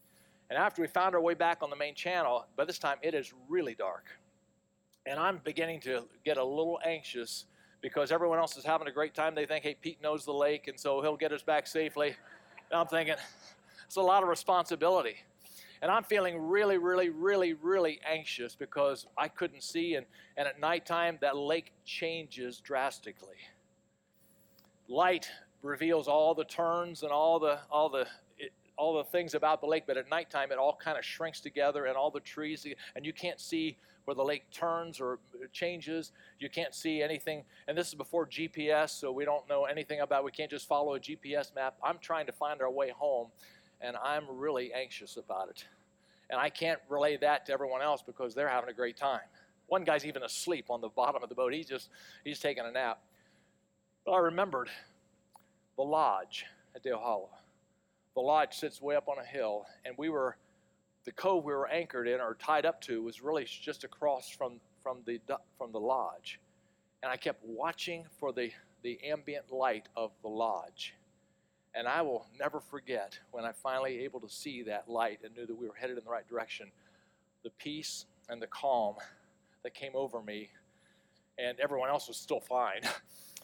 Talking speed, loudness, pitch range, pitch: 195 wpm, -34 LUFS, 135-165 Hz, 150 Hz